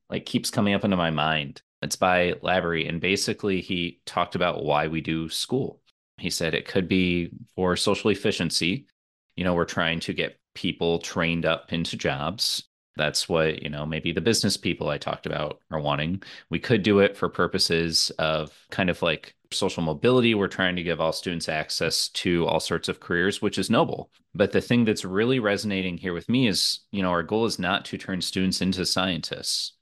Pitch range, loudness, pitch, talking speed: 80-100 Hz, -25 LUFS, 90 Hz, 200 wpm